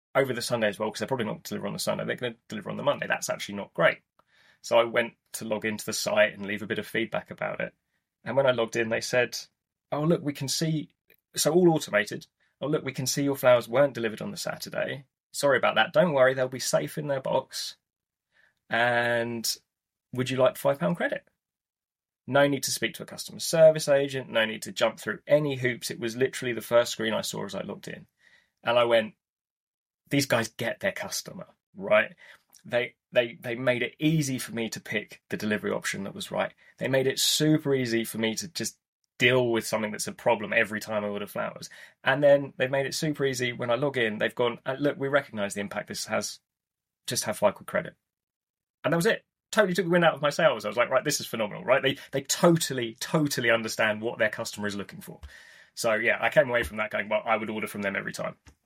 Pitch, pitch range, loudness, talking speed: 125 Hz, 115-140 Hz, -27 LUFS, 235 wpm